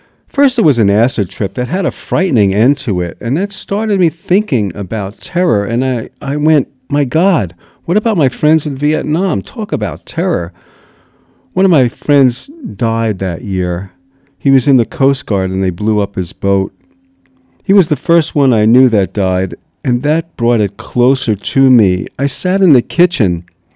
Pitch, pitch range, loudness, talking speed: 125 Hz, 100-155 Hz, -13 LUFS, 190 wpm